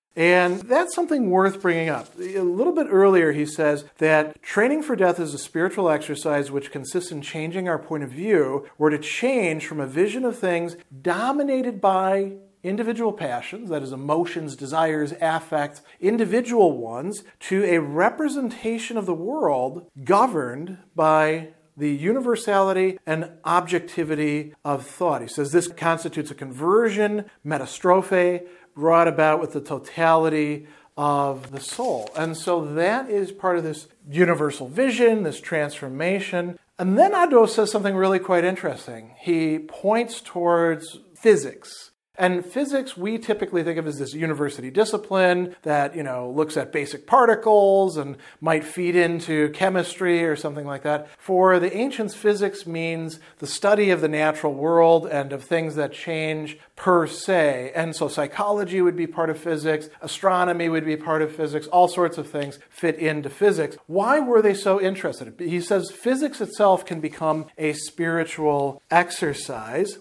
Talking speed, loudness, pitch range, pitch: 155 wpm, -22 LUFS, 155-195 Hz, 170 Hz